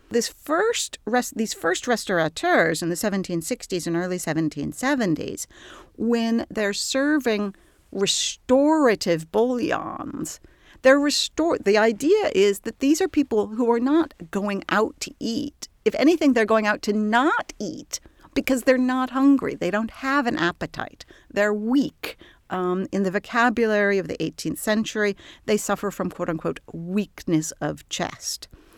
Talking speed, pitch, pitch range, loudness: 140 wpm, 220 Hz, 195-265 Hz, -23 LUFS